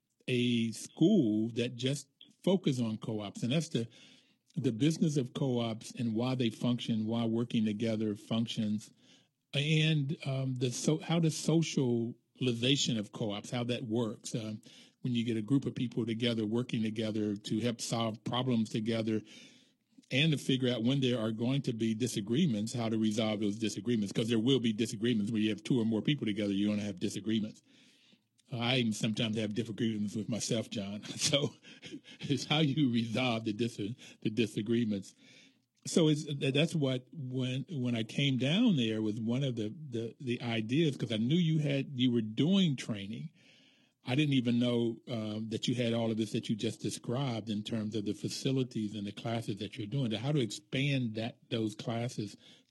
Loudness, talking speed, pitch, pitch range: -33 LUFS, 180 wpm, 120 Hz, 110-135 Hz